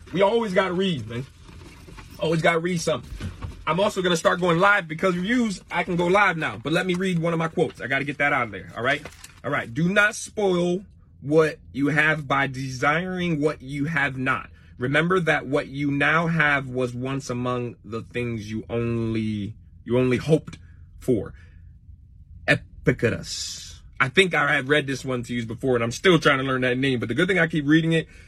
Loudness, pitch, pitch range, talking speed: -23 LUFS, 140 Hz, 115-165 Hz, 205 wpm